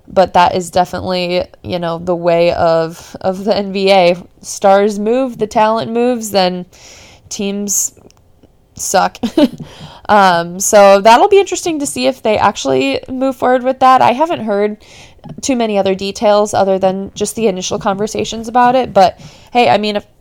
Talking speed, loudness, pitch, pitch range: 160 wpm, -13 LUFS, 205 Hz, 185-235 Hz